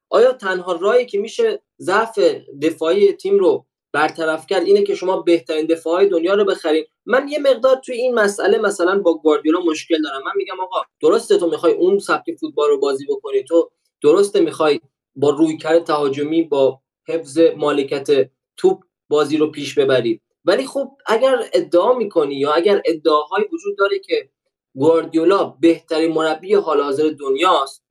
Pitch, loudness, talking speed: 200 Hz, -17 LUFS, 155 wpm